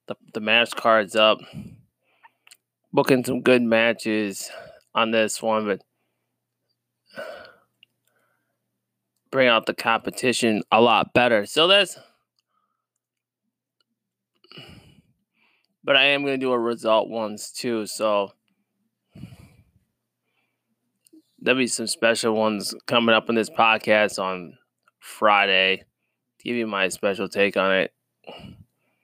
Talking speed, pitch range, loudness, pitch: 105 wpm, 100-125 Hz, -21 LUFS, 110 Hz